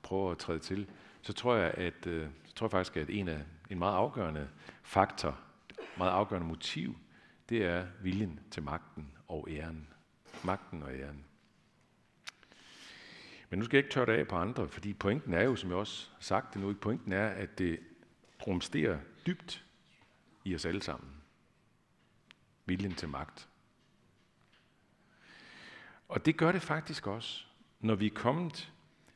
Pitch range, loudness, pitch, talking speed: 80-110 Hz, -35 LUFS, 95 Hz, 155 wpm